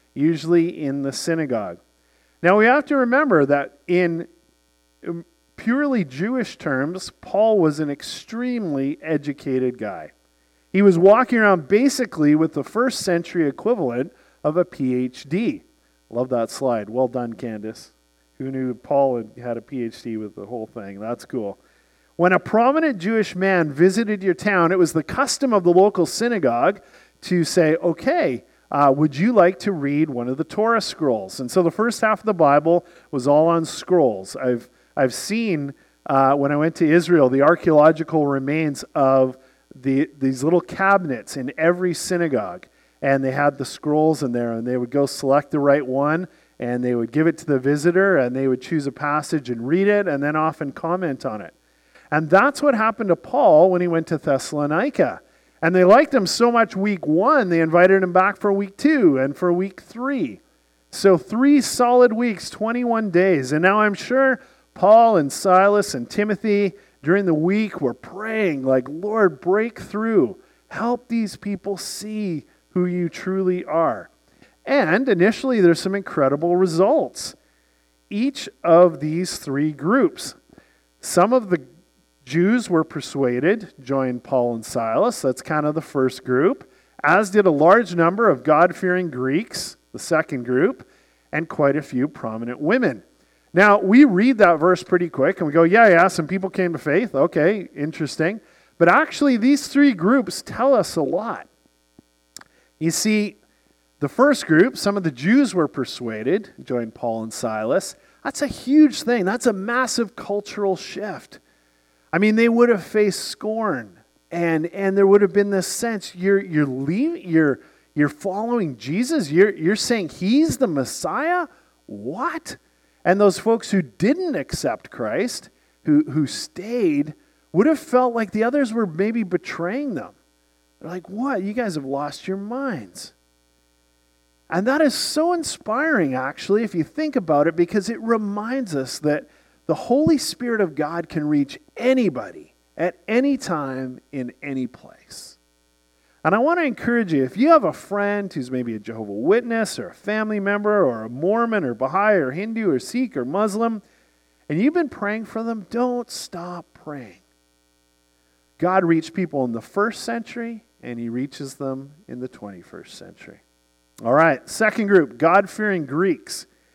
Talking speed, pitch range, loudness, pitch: 165 wpm, 135-215 Hz, -20 LUFS, 175 Hz